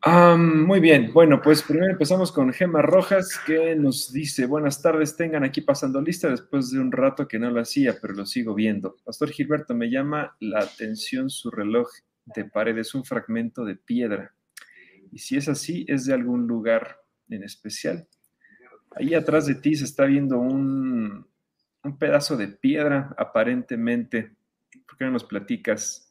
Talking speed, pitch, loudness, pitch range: 170 wpm, 150 Hz, -22 LUFS, 130-195 Hz